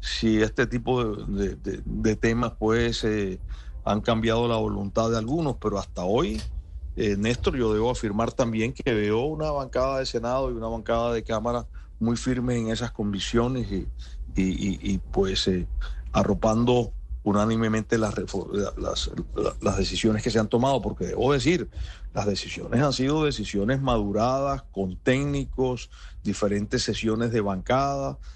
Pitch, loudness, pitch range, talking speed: 110 Hz, -26 LUFS, 100-120 Hz, 155 wpm